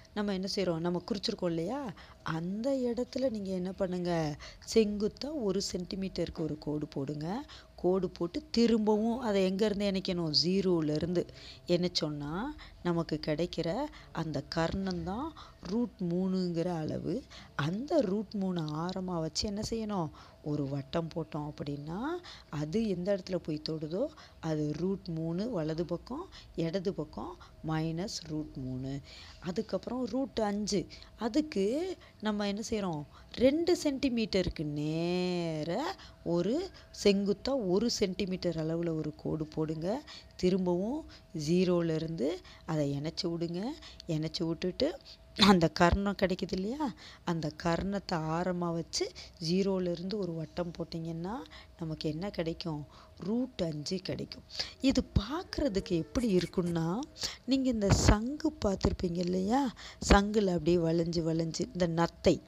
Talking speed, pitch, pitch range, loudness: 110 wpm, 180 Hz, 165-210 Hz, -33 LUFS